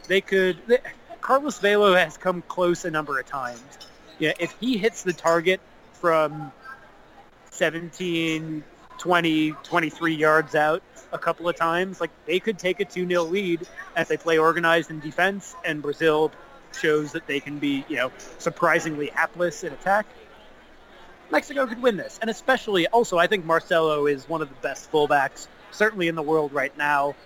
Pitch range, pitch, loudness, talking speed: 155-185 Hz, 170 Hz, -23 LUFS, 170 wpm